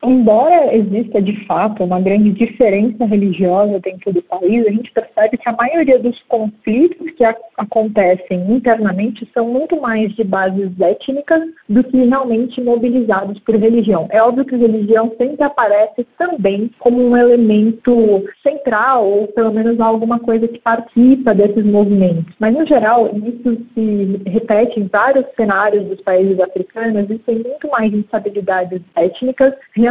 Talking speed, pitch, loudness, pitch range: 150 wpm, 225 Hz, -14 LUFS, 205-245 Hz